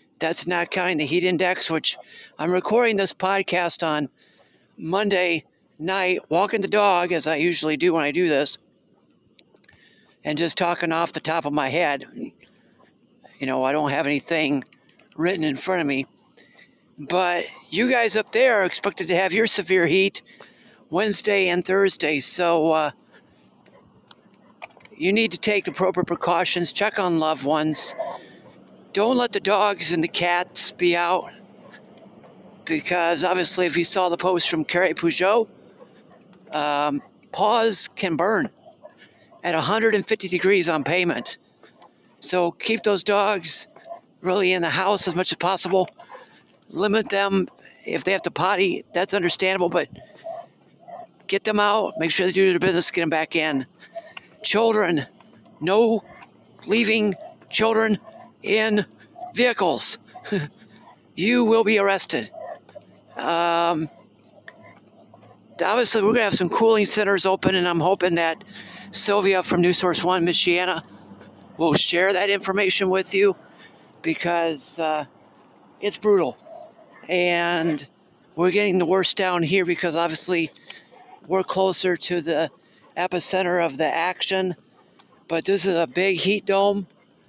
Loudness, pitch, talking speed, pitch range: -21 LUFS, 185 Hz, 135 wpm, 170-205 Hz